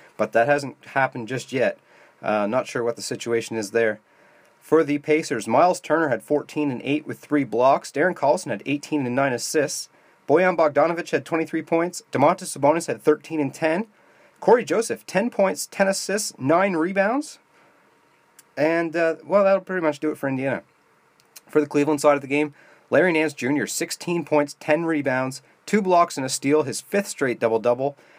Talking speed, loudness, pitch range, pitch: 185 wpm, -22 LUFS, 135-170 Hz, 150 Hz